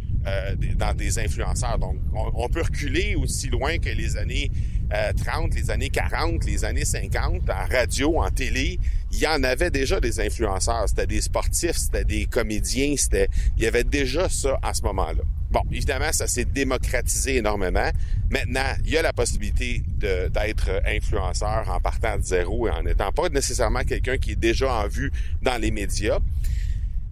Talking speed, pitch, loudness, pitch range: 180 wpm, 90 Hz, -25 LUFS, 80-105 Hz